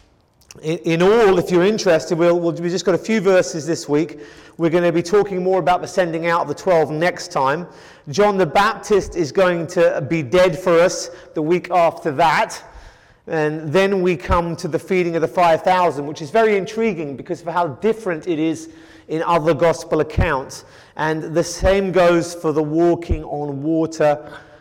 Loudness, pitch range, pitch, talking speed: -18 LUFS, 160-180 Hz, 170 Hz, 190 wpm